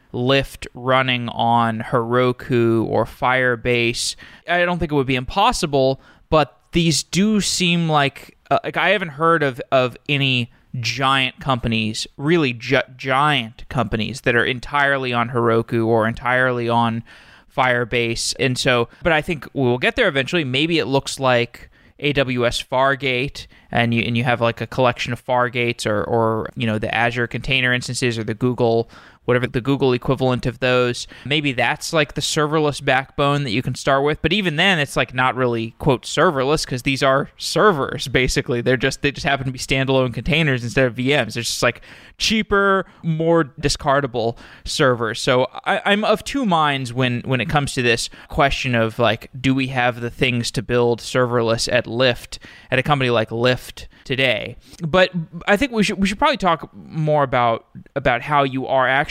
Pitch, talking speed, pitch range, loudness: 130 Hz, 175 wpm, 120-145 Hz, -19 LUFS